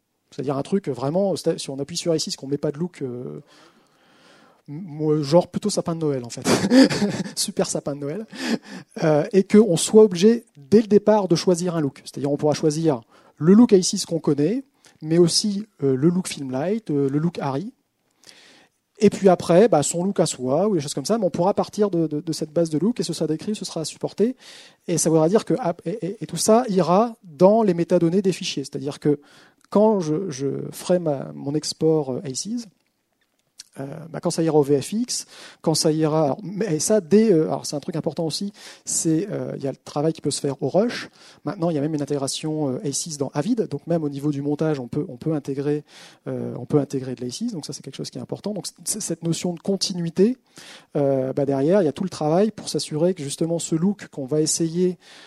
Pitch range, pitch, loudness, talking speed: 145-195 Hz, 165 Hz, -22 LUFS, 225 wpm